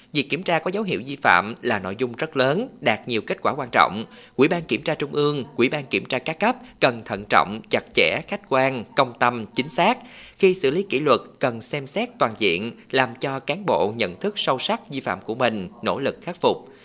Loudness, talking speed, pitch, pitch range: -22 LUFS, 240 wpm, 145 Hz, 130-200 Hz